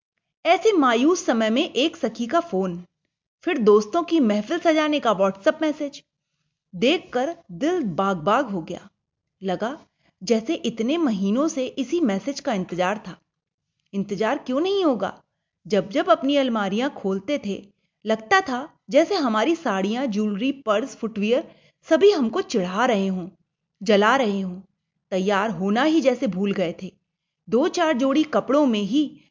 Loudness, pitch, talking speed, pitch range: -22 LUFS, 225 Hz, 145 wpm, 190-290 Hz